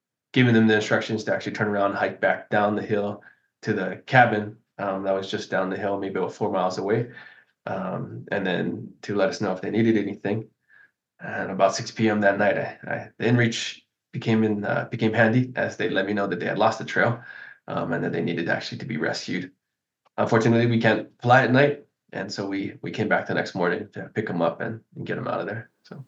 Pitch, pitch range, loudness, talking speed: 110 Hz, 100-115 Hz, -24 LUFS, 235 wpm